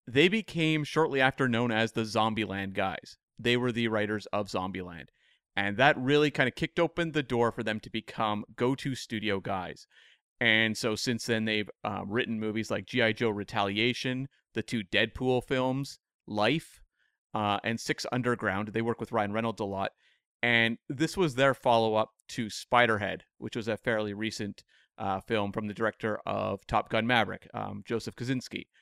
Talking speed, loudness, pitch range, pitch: 175 wpm, -29 LUFS, 105-125 Hz, 115 Hz